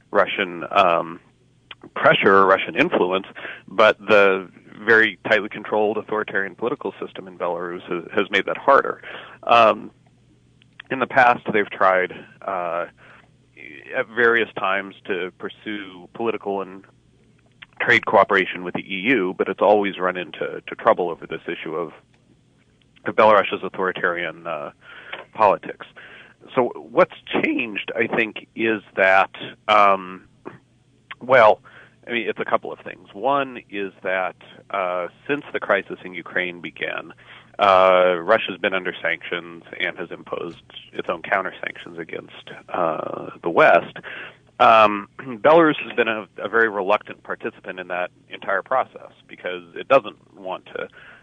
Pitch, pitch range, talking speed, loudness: 100 Hz, 95-115 Hz, 135 wpm, -20 LUFS